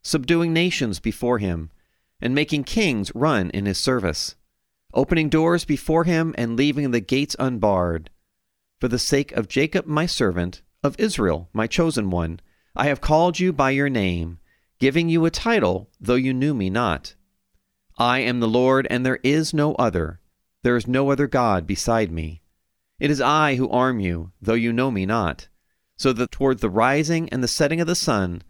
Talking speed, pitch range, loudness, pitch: 180 wpm, 95-145 Hz, -21 LUFS, 125 Hz